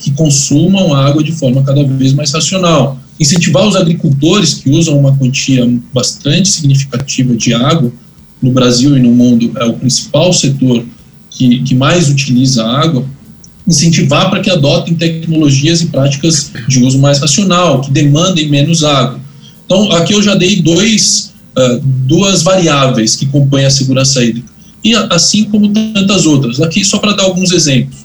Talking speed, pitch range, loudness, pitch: 165 wpm, 130-175 Hz, -9 LUFS, 145 Hz